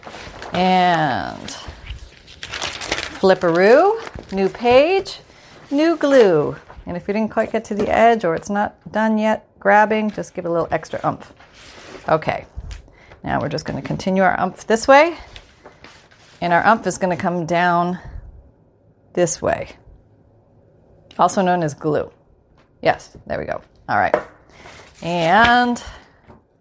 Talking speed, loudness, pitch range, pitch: 135 wpm, -18 LUFS, 175-225 Hz, 195 Hz